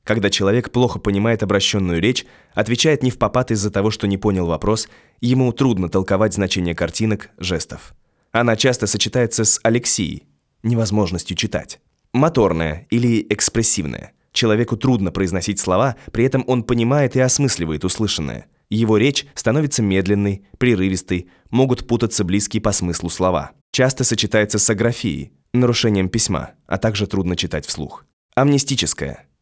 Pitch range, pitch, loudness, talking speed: 95-120 Hz, 105 Hz, -18 LUFS, 135 wpm